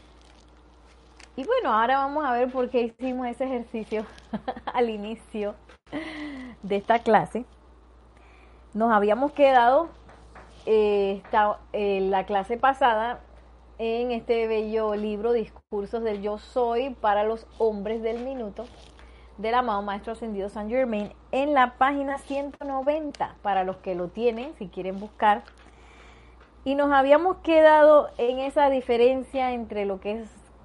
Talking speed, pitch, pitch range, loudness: 125 wpm, 230 Hz, 205-260 Hz, -25 LUFS